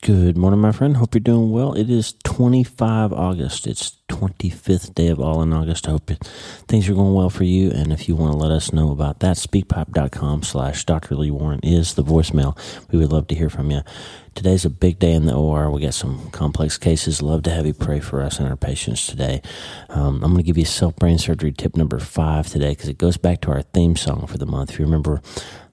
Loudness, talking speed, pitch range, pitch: -19 LUFS, 235 wpm, 75-95 Hz, 80 Hz